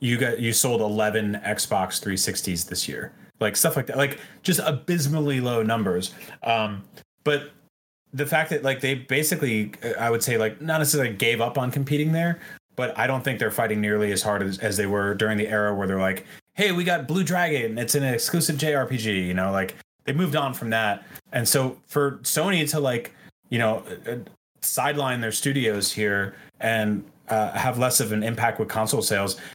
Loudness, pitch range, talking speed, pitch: -24 LUFS, 105-145 Hz, 195 wpm, 120 Hz